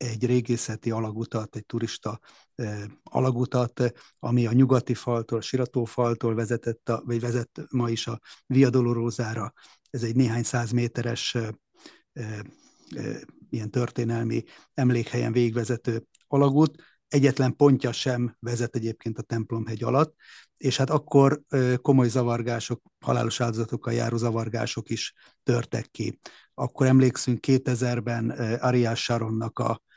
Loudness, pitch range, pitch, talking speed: -26 LUFS, 115-125 Hz, 120 Hz, 125 wpm